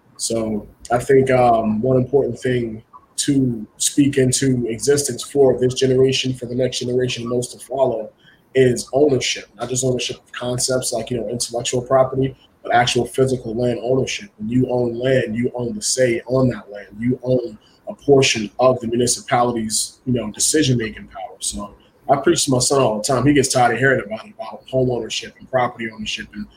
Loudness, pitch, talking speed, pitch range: -19 LUFS, 125 Hz, 185 wpm, 115-130 Hz